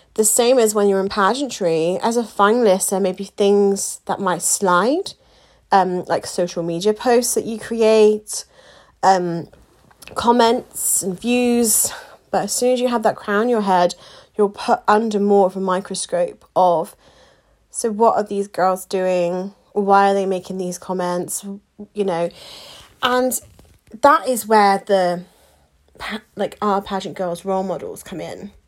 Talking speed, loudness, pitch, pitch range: 160 wpm, -18 LUFS, 200 Hz, 185-225 Hz